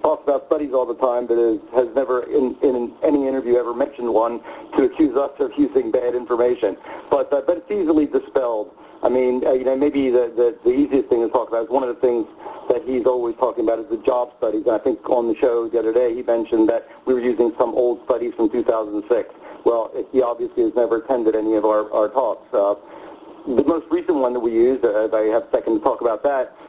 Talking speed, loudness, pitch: 245 wpm, -20 LUFS, 130 Hz